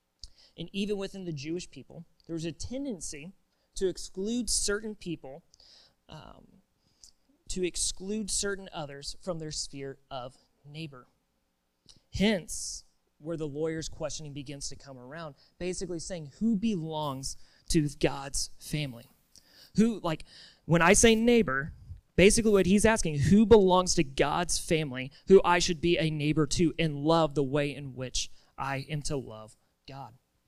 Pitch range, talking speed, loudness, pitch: 140-185 Hz, 145 wpm, -28 LUFS, 160 Hz